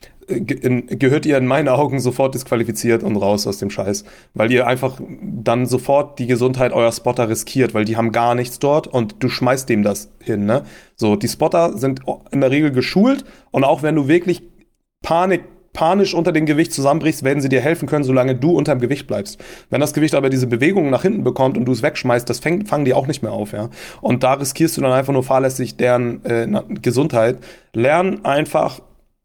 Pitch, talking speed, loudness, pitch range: 130 Hz, 205 wpm, -17 LUFS, 120-150 Hz